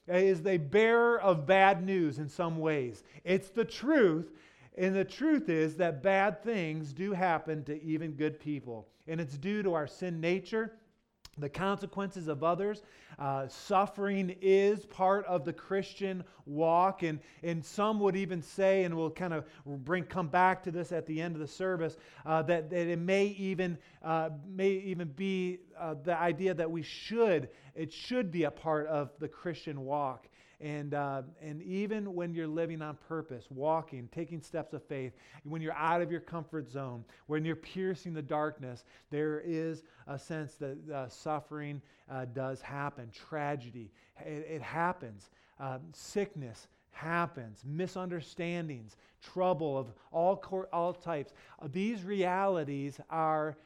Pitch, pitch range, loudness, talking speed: 165 Hz, 150-185 Hz, -33 LUFS, 160 wpm